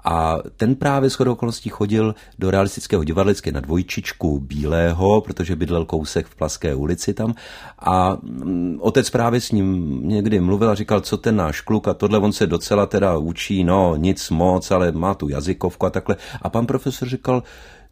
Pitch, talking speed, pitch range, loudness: 95 Hz, 175 wpm, 85-110 Hz, -20 LUFS